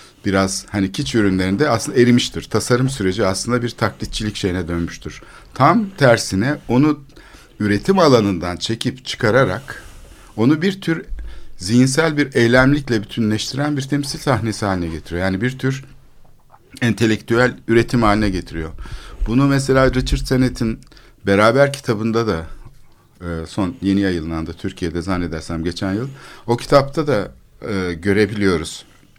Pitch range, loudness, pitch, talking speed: 95-130 Hz, -18 LUFS, 115 Hz, 115 wpm